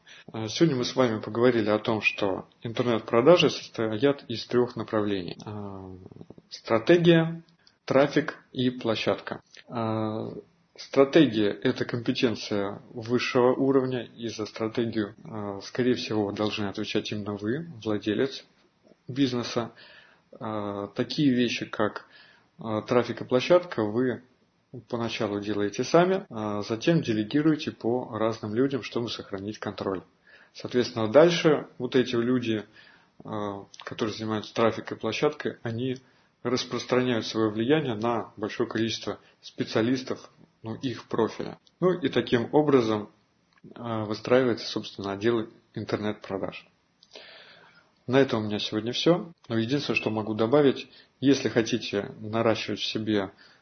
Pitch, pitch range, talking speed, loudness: 115 Hz, 110-130 Hz, 105 wpm, -27 LUFS